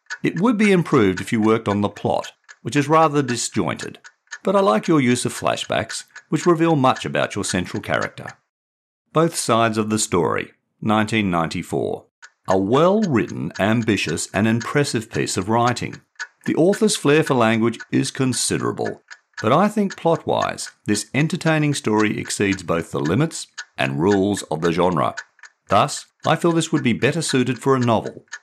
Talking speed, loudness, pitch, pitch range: 165 wpm, -20 LUFS, 120 Hz, 105-155 Hz